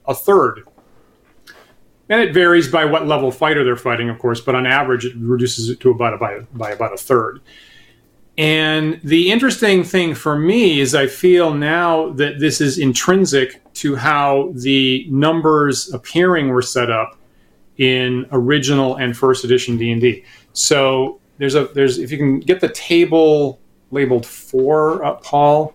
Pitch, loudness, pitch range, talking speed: 140 Hz, -15 LUFS, 125-155 Hz, 170 wpm